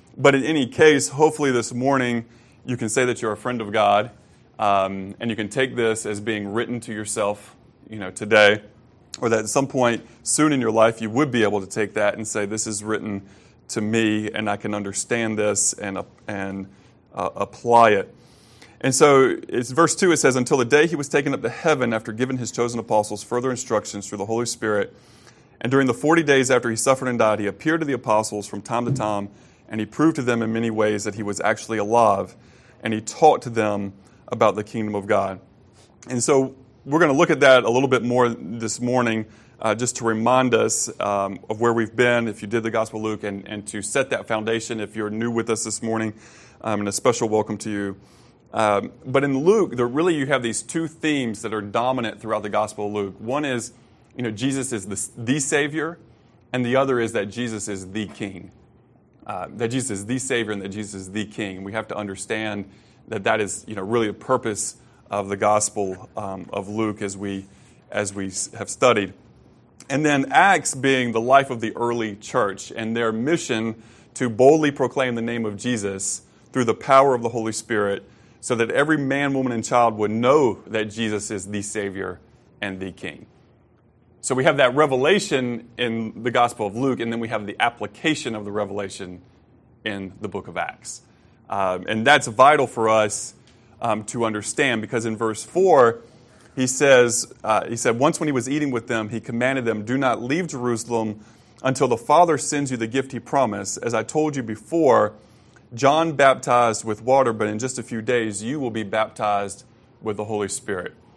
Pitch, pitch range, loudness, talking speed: 115 Hz, 105-125 Hz, -22 LUFS, 210 wpm